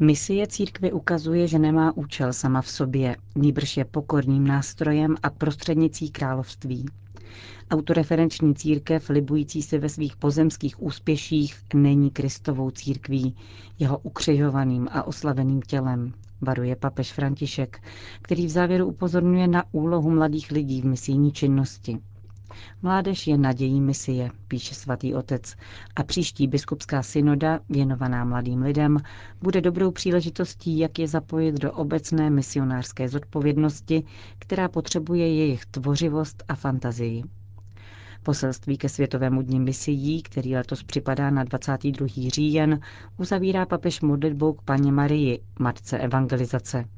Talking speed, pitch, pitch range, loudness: 120 wpm, 140 Hz, 130-155 Hz, -24 LUFS